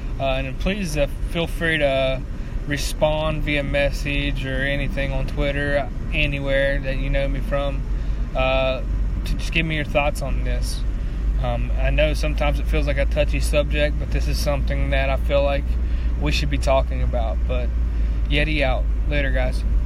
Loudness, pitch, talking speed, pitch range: -23 LUFS, 140 Hz, 170 wpm, 100-145 Hz